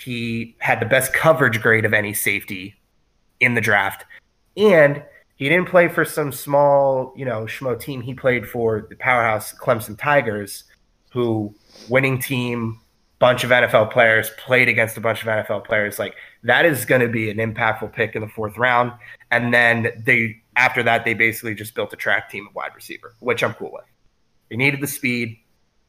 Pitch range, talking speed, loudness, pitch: 110-130 Hz, 185 wpm, -18 LUFS, 120 Hz